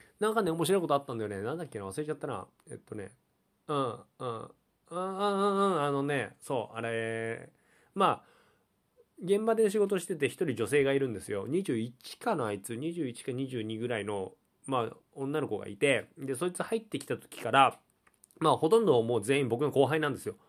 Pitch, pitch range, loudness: 145 Hz, 120-190 Hz, -31 LUFS